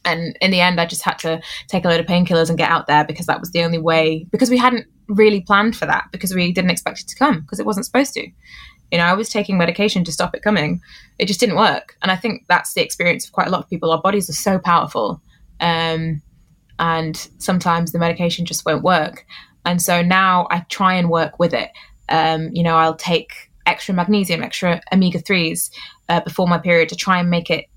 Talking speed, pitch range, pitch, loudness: 235 wpm, 165-190 Hz, 175 Hz, -17 LUFS